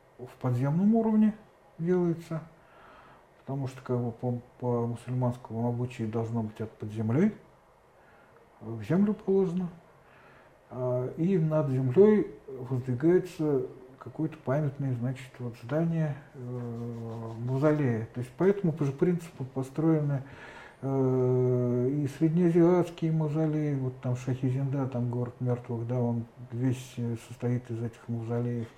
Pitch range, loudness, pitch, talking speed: 120-160 Hz, -29 LUFS, 130 Hz, 115 wpm